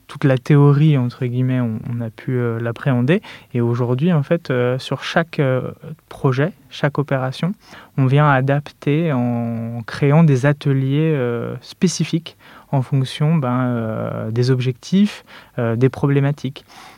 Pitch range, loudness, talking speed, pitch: 125-150 Hz, -18 LUFS, 140 wpm, 135 Hz